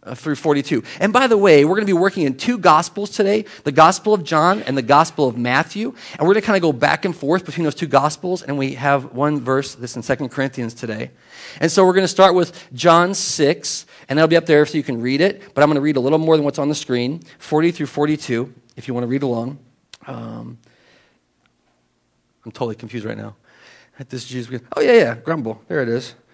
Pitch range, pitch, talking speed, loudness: 130-170 Hz, 150 Hz, 235 wpm, -17 LUFS